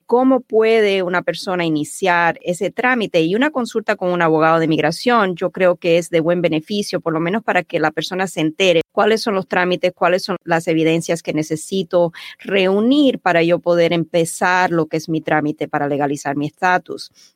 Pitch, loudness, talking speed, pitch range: 175 Hz, -17 LUFS, 190 wpm, 165-195 Hz